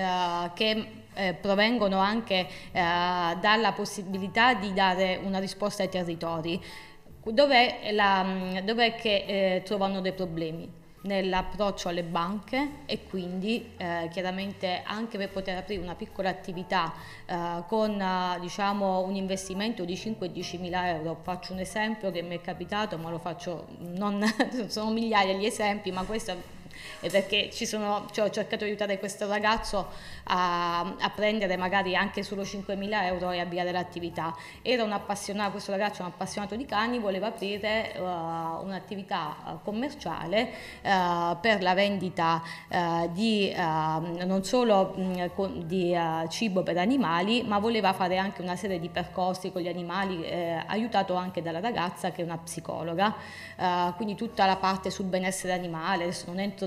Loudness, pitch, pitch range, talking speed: -29 LUFS, 190 Hz, 180-205 Hz, 150 wpm